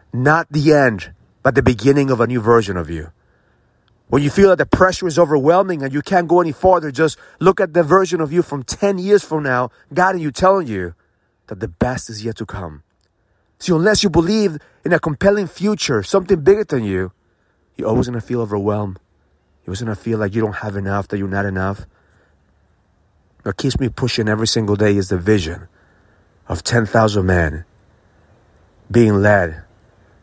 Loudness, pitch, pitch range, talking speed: -17 LUFS, 115 Hz, 95-155 Hz, 195 wpm